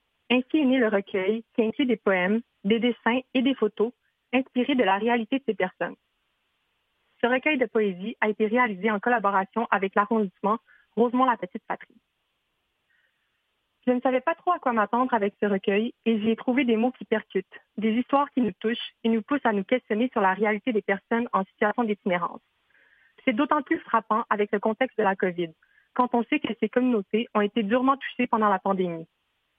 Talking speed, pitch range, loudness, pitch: 195 wpm, 210-250 Hz, -25 LUFS, 225 Hz